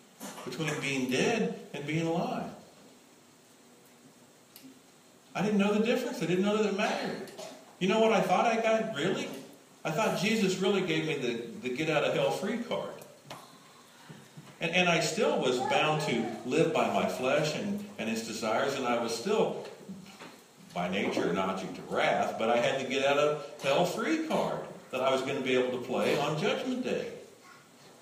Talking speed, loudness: 180 wpm, -30 LUFS